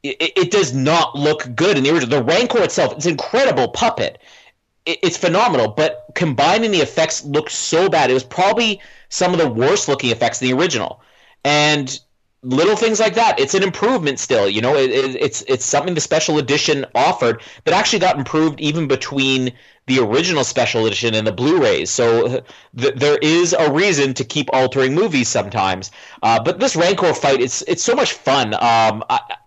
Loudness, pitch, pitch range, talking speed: -16 LUFS, 150 Hz, 130-185 Hz, 190 wpm